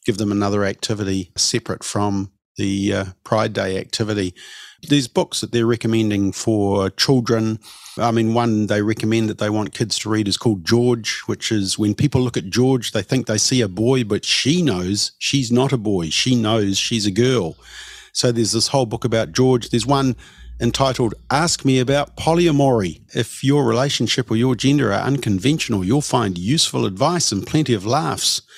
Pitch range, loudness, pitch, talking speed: 105-130 Hz, -19 LUFS, 115 Hz, 185 wpm